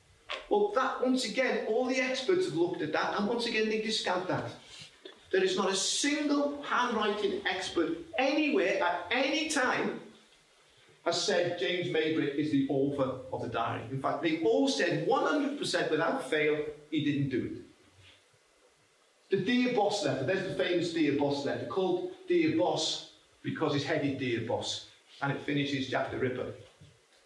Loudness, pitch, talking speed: -30 LUFS, 190 Hz, 165 wpm